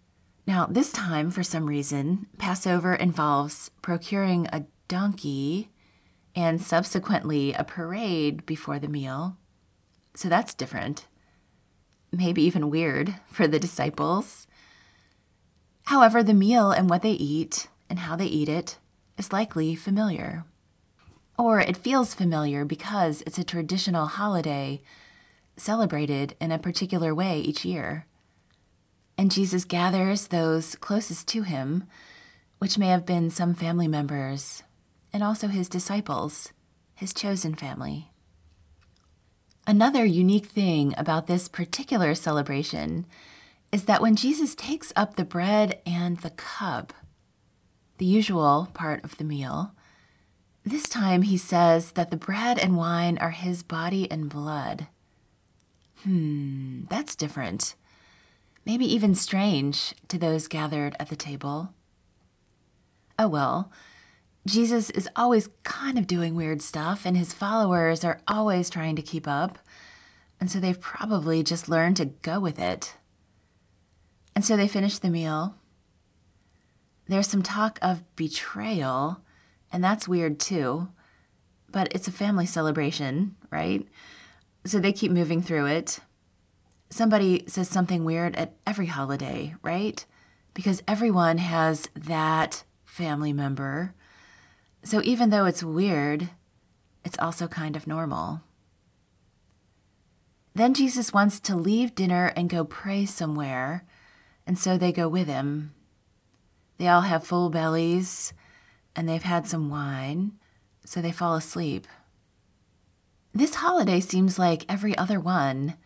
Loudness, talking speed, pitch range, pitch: -26 LUFS, 125 wpm, 145-190 Hz, 170 Hz